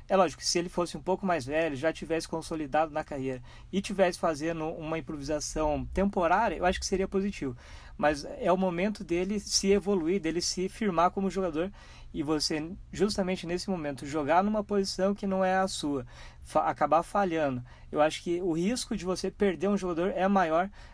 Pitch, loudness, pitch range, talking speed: 175 Hz, -29 LUFS, 155-195 Hz, 185 wpm